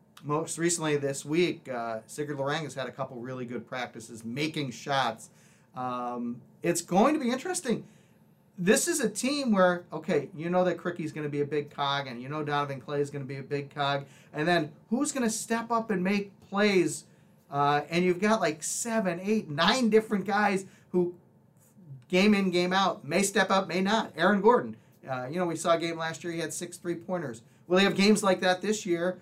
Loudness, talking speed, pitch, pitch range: -28 LUFS, 215 wpm, 170 Hz, 145-195 Hz